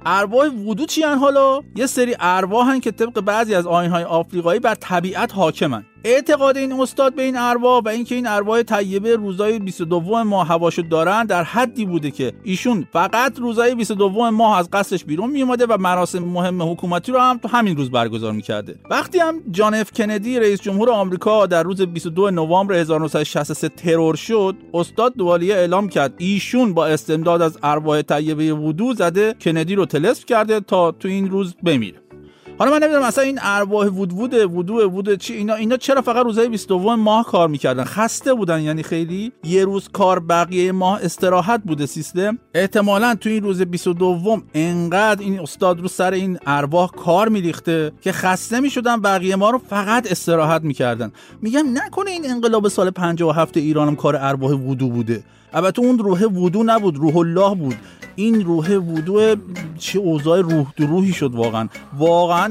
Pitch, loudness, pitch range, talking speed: 190 Hz, -18 LUFS, 165-225 Hz, 175 wpm